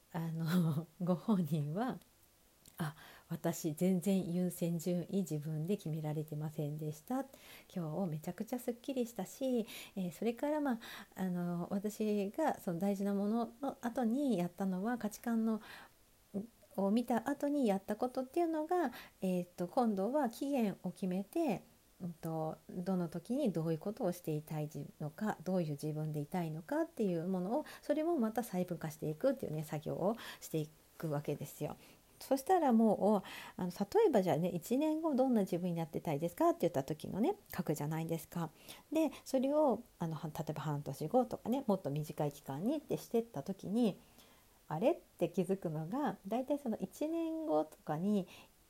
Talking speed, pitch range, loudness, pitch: 325 characters per minute, 165-245 Hz, -37 LUFS, 190 Hz